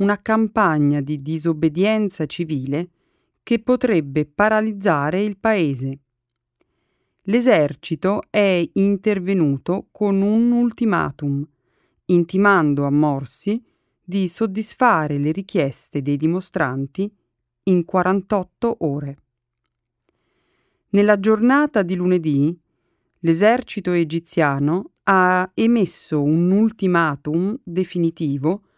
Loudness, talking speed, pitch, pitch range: -19 LUFS, 80 wpm, 180 Hz, 150-205 Hz